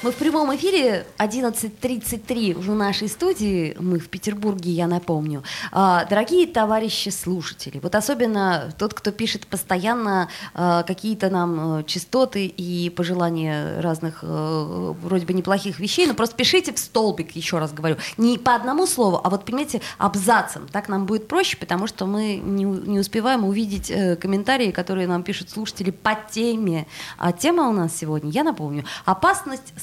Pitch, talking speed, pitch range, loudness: 195 Hz, 145 wpm, 175-225 Hz, -22 LUFS